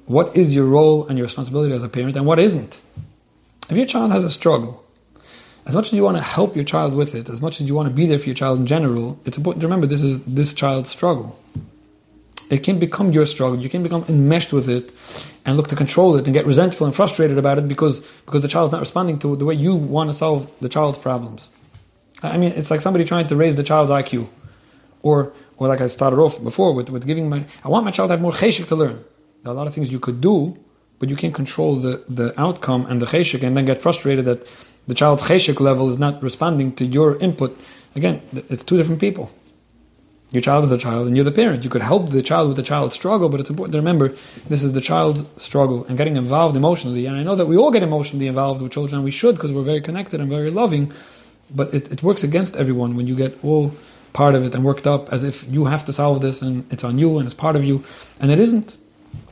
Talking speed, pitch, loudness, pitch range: 255 wpm, 145 Hz, -18 LUFS, 130-160 Hz